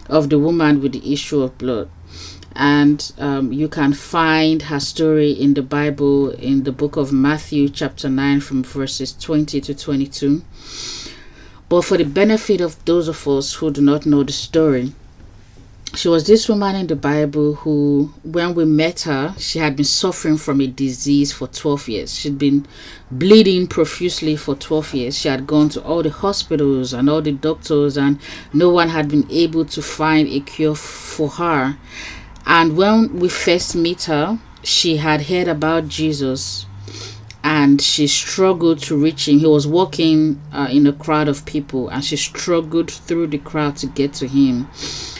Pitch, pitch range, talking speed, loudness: 150 Hz, 140-160 Hz, 175 wpm, -17 LUFS